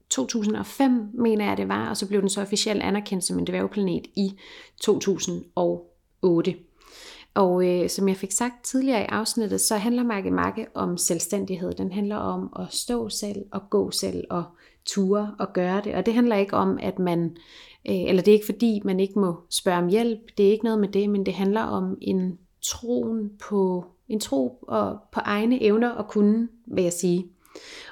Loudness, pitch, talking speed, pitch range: -25 LUFS, 200 Hz, 190 wpm, 180-220 Hz